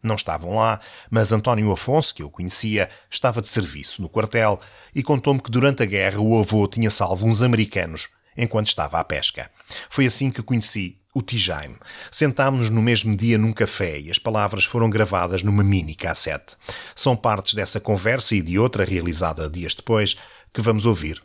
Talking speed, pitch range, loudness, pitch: 180 wpm, 95-115 Hz, -20 LUFS, 110 Hz